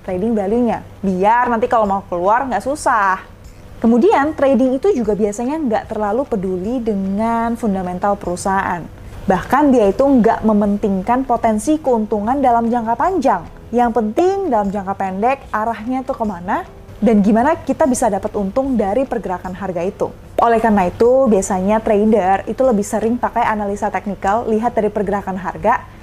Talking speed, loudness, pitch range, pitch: 145 wpm, -16 LUFS, 205-245 Hz, 225 Hz